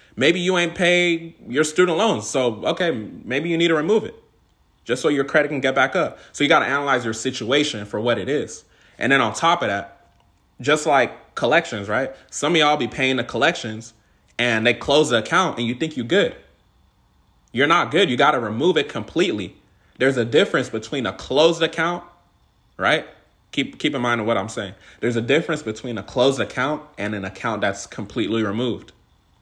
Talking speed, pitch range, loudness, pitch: 200 wpm, 110-160 Hz, -20 LUFS, 125 Hz